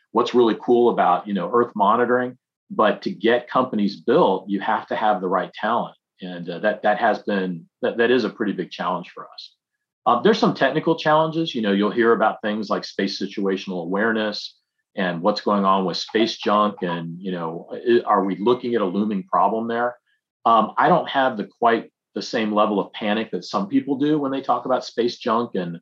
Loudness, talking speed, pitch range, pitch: -21 LUFS, 210 wpm, 95-120 Hz, 105 Hz